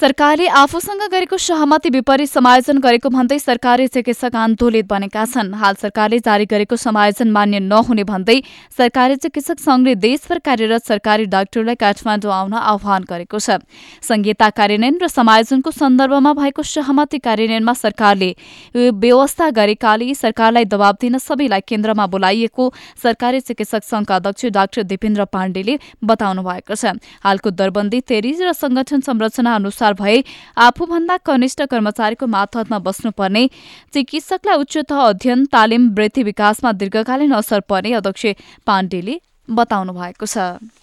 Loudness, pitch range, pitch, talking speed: -15 LUFS, 210-270 Hz, 230 Hz, 130 wpm